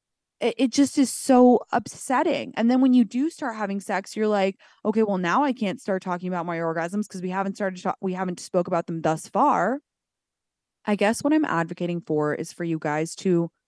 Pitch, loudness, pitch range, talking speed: 195 Hz, -24 LUFS, 175-235 Hz, 215 wpm